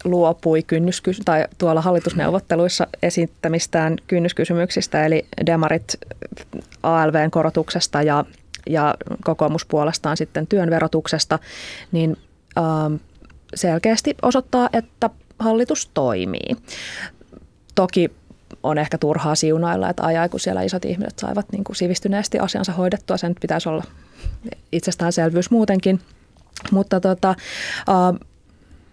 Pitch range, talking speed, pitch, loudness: 160-190 Hz, 95 wpm, 170 Hz, -20 LUFS